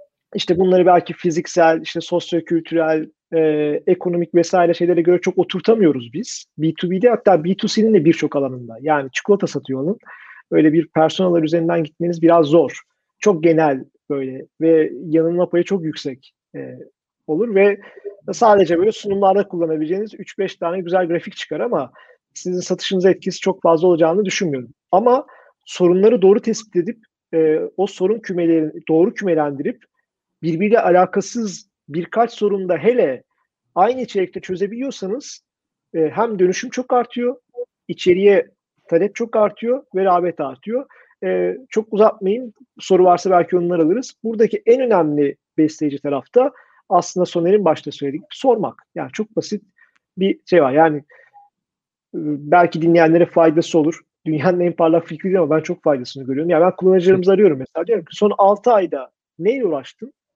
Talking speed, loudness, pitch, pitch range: 140 wpm, -17 LUFS, 180 Hz, 165-210 Hz